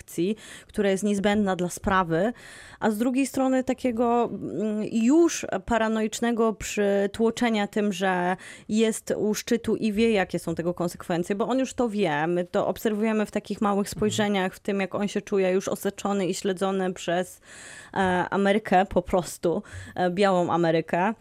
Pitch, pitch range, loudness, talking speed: 205 Hz, 185-220 Hz, -25 LUFS, 145 wpm